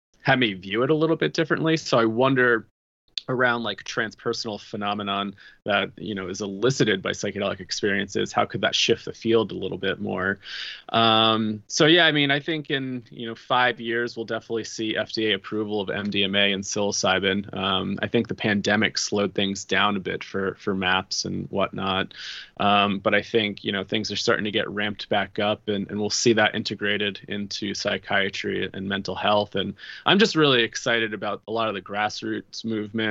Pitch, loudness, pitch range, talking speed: 110 Hz, -24 LUFS, 100-120 Hz, 190 wpm